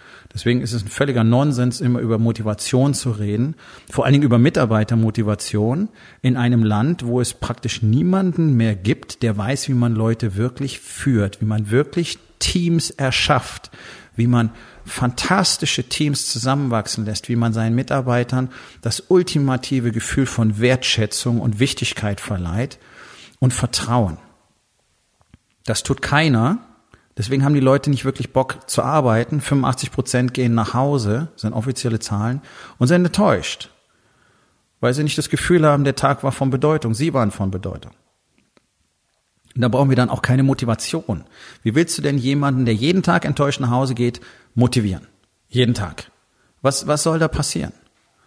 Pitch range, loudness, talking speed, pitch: 115-140 Hz, -19 LUFS, 155 wpm, 125 Hz